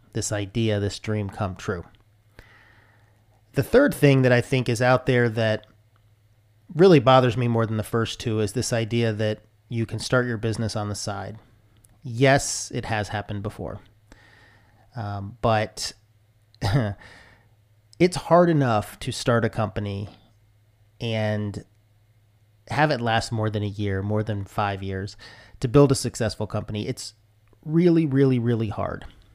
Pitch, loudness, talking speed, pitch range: 110 Hz, -23 LUFS, 145 wpm, 105-120 Hz